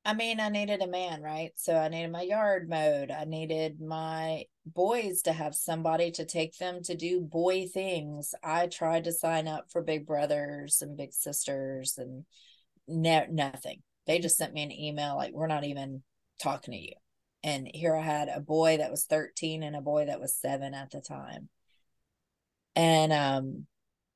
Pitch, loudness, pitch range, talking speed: 160 Hz, -31 LUFS, 145-170 Hz, 185 wpm